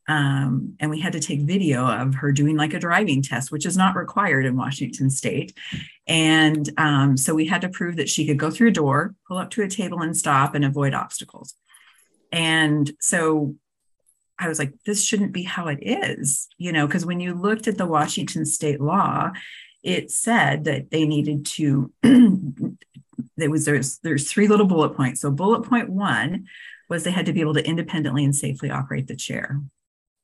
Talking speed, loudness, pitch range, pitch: 195 wpm, -21 LUFS, 140-180 Hz, 155 Hz